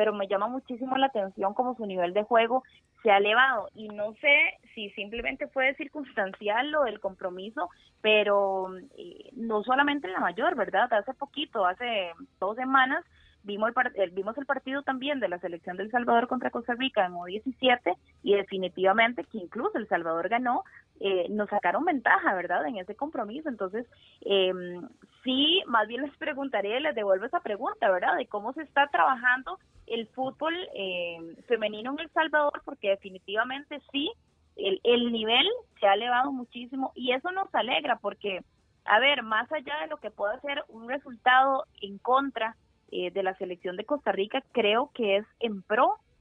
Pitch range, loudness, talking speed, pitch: 200-275 Hz, -28 LUFS, 170 wpm, 235 Hz